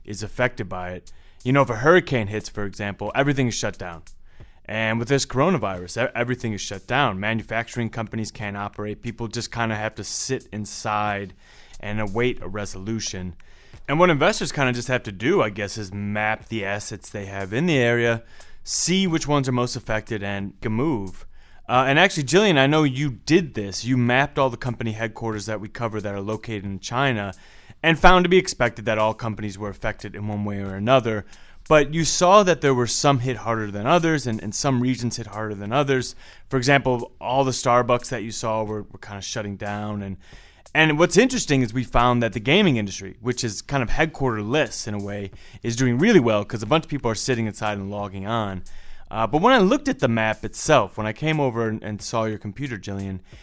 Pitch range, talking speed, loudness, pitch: 105-130 Hz, 215 wpm, -22 LUFS, 115 Hz